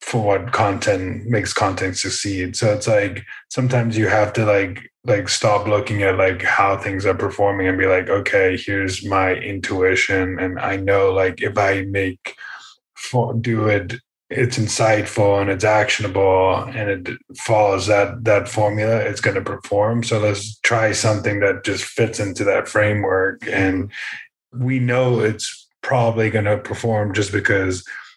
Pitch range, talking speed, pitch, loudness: 95-110 Hz, 160 wpm, 105 Hz, -19 LUFS